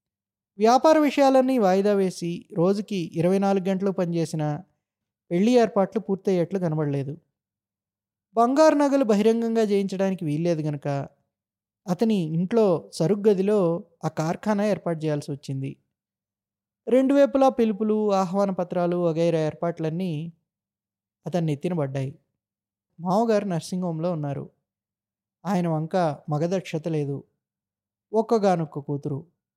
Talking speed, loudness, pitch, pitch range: 95 wpm, -24 LUFS, 170 Hz, 145-200 Hz